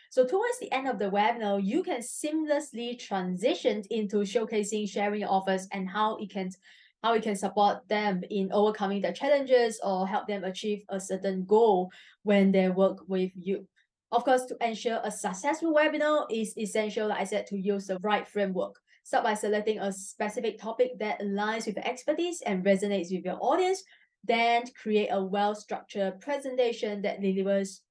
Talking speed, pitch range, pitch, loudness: 170 wpm, 195-235 Hz, 210 Hz, -29 LUFS